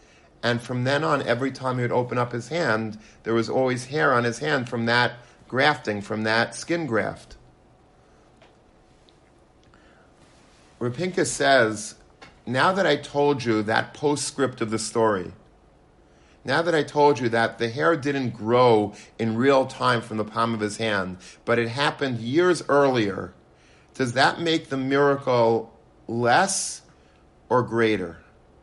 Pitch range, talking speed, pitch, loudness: 110-140 Hz, 145 wpm, 120 Hz, -23 LUFS